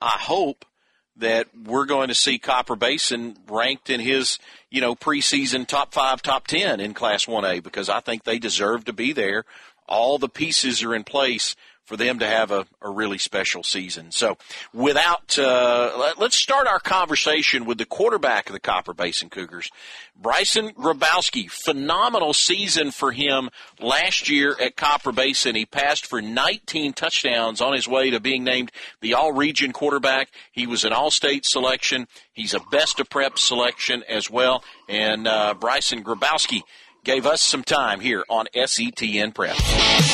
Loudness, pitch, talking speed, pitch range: -21 LUFS, 130 Hz, 170 wpm, 115-145 Hz